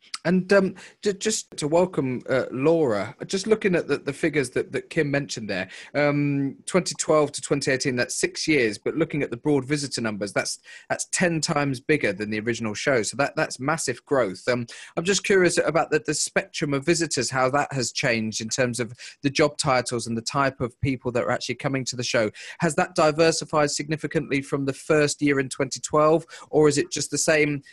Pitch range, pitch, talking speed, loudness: 130-160 Hz, 145 Hz, 210 wpm, -24 LUFS